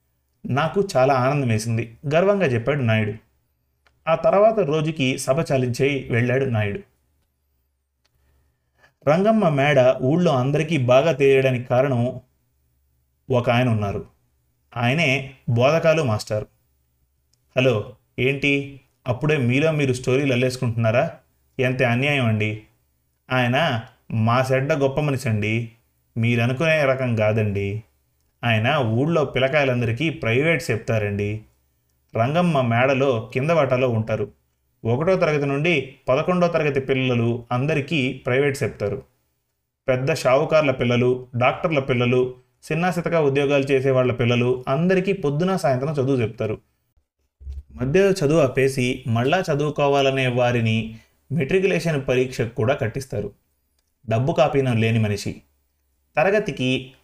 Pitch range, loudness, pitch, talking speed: 110-140 Hz, -21 LUFS, 125 Hz, 100 wpm